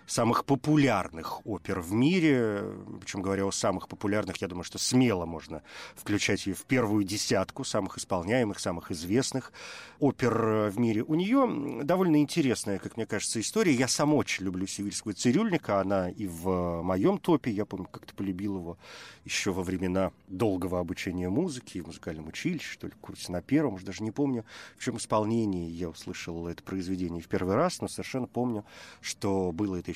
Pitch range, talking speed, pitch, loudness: 95-125 Hz, 170 wpm, 100 Hz, -29 LUFS